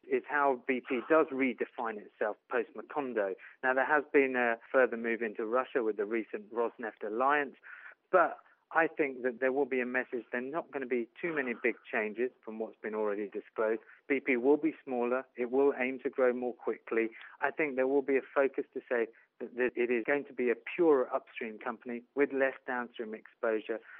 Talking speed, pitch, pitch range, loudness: 200 wpm, 130 Hz, 120-140 Hz, -32 LUFS